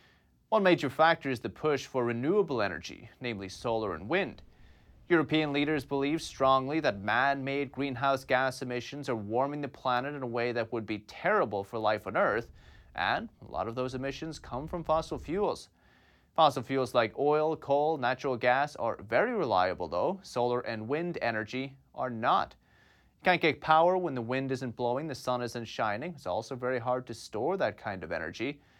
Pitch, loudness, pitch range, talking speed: 130 Hz, -31 LUFS, 120-145 Hz, 185 wpm